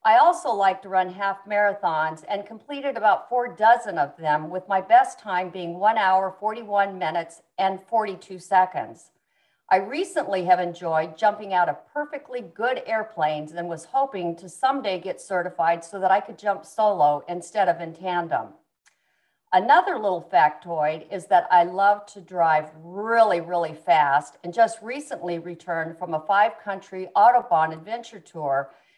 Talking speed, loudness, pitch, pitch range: 155 wpm, -23 LUFS, 185 Hz, 170-215 Hz